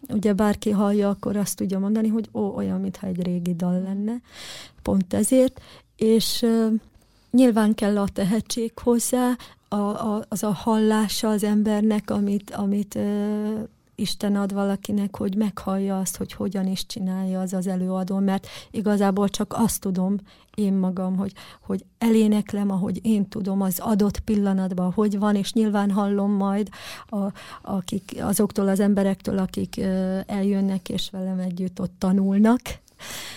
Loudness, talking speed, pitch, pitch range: -23 LUFS, 145 wpm, 205 Hz, 195-215 Hz